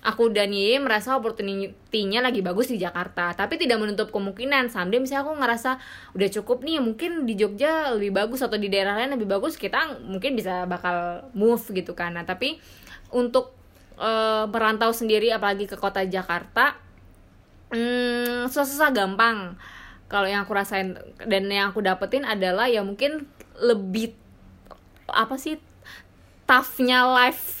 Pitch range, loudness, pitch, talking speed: 195-250 Hz, -24 LUFS, 220 Hz, 145 wpm